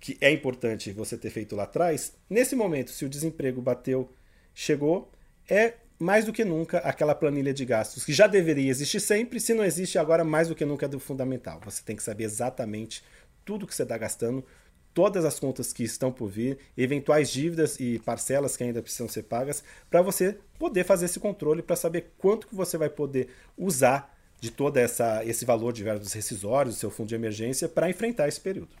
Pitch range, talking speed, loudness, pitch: 120-170 Hz, 200 wpm, -27 LUFS, 140 Hz